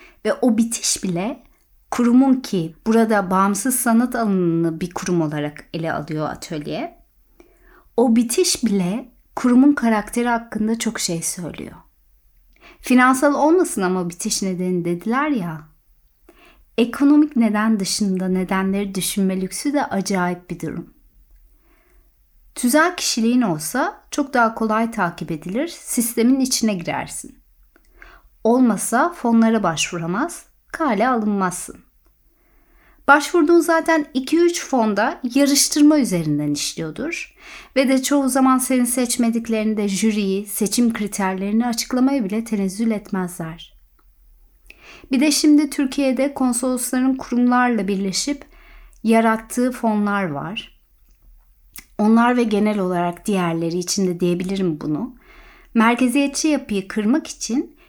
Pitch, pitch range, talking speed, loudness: 230 Hz, 190-270 Hz, 105 wpm, -19 LUFS